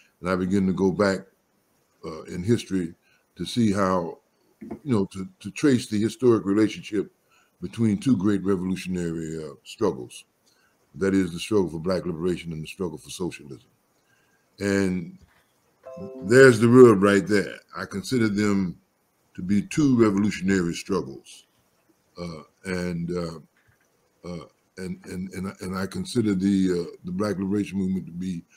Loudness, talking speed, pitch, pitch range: -23 LUFS, 145 wpm, 95 Hz, 90-105 Hz